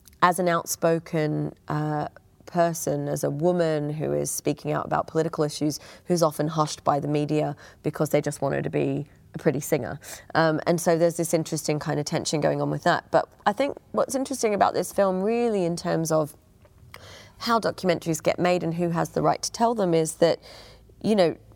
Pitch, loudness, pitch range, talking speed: 160 Hz, -25 LUFS, 145-175 Hz, 200 wpm